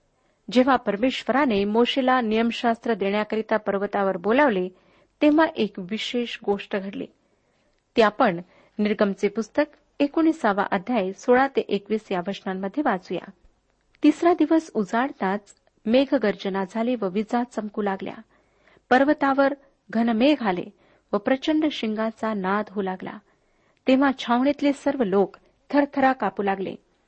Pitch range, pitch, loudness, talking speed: 200-265 Hz, 220 Hz, -23 LUFS, 110 wpm